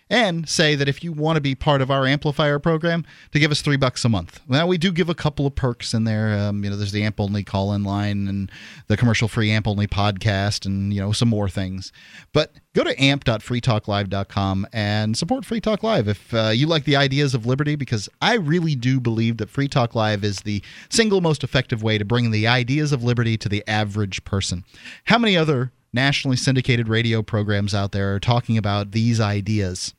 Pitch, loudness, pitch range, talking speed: 115 Hz, -21 LUFS, 105-145 Hz, 220 wpm